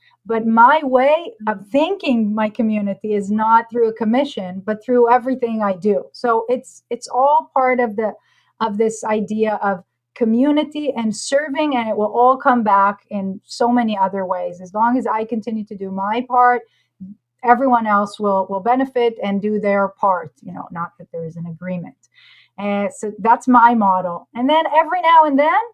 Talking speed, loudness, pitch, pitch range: 185 wpm, -17 LUFS, 225 Hz, 200-255 Hz